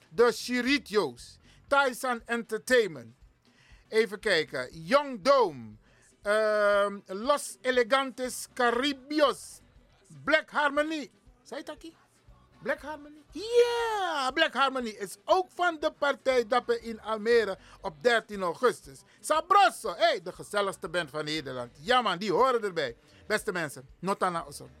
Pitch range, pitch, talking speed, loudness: 200-290 Hz, 240 Hz, 125 wpm, -28 LUFS